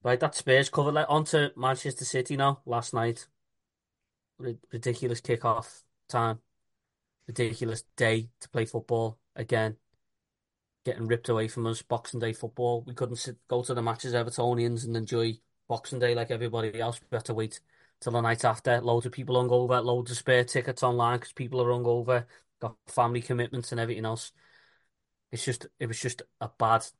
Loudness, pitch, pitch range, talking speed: -29 LUFS, 120 Hz, 115-125 Hz, 180 wpm